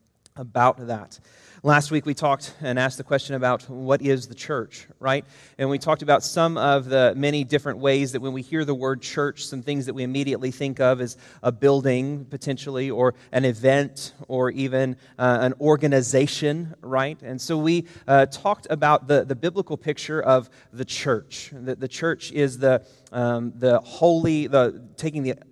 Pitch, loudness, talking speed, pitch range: 135 Hz, -23 LUFS, 180 wpm, 130-145 Hz